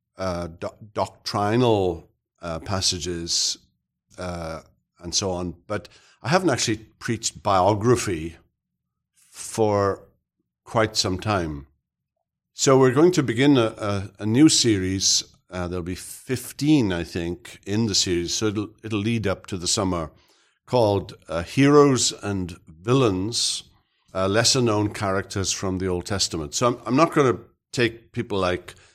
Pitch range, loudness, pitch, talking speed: 90-115 Hz, -22 LUFS, 100 Hz, 140 wpm